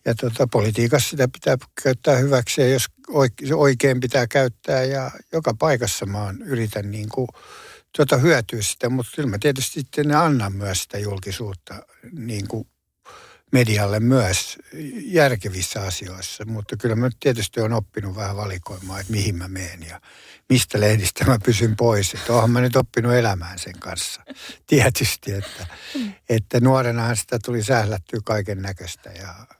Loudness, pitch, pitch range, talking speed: -21 LUFS, 115 Hz, 100-130 Hz, 155 wpm